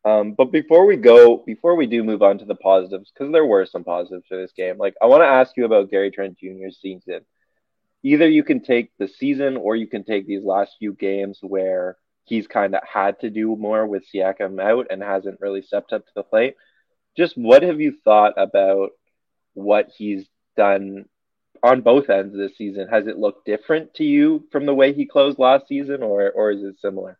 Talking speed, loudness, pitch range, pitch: 215 wpm, -18 LUFS, 95-140 Hz, 105 Hz